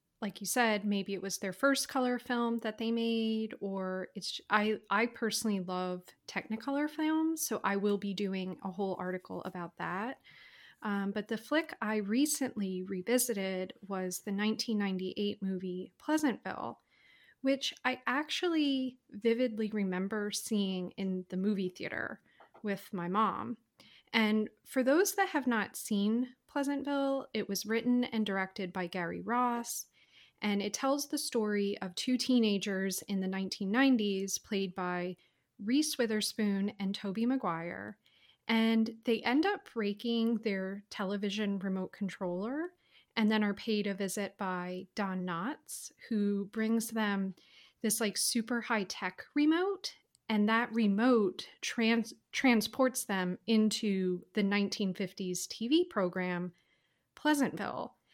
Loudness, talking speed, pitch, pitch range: -33 LUFS, 135 wpm, 215 Hz, 195-245 Hz